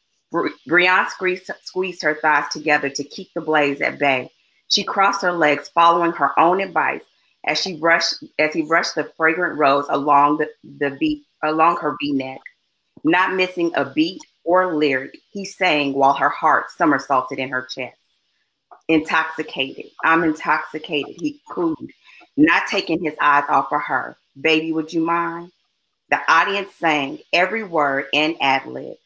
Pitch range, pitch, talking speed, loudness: 145-185 Hz, 160 Hz, 155 wpm, -19 LUFS